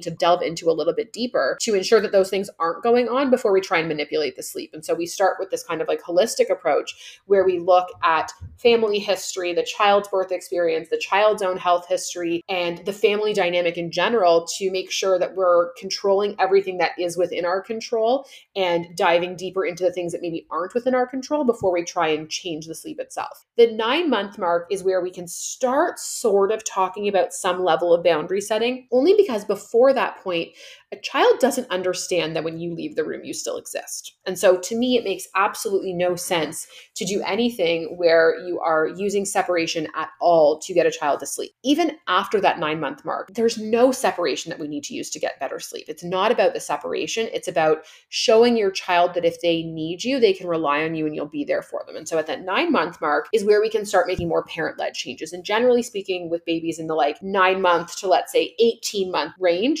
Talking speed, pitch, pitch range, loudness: 225 wpm, 190 Hz, 175-235 Hz, -21 LUFS